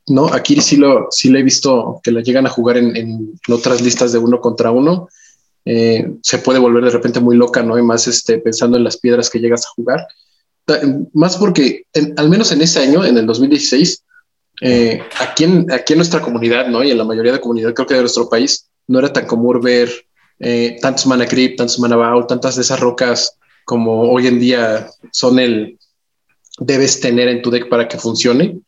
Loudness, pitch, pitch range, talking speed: -13 LUFS, 125 Hz, 120-135 Hz, 215 wpm